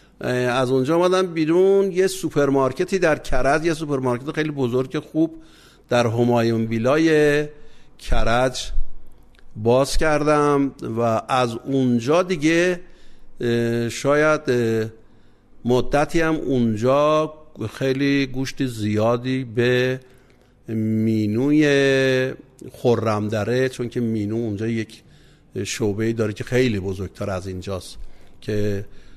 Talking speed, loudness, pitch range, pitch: 95 wpm, -21 LUFS, 115-150 Hz, 125 Hz